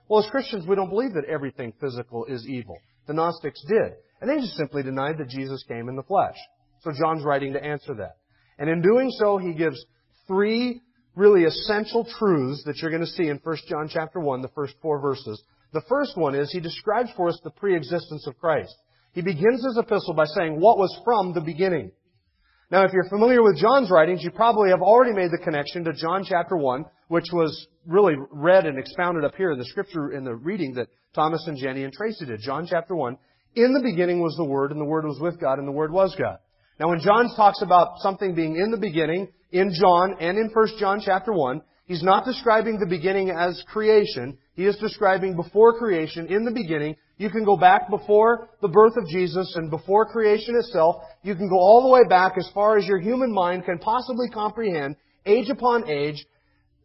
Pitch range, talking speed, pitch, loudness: 150-205 Hz, 215 wpm, 175 Hz, -22 LUFS